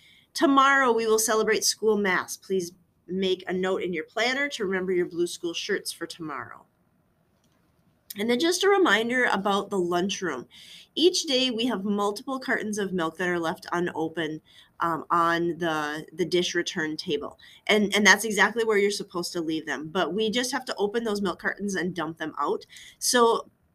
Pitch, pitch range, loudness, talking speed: 195 Hz, 175-225 Hz, -25 LUFS, 180 wpm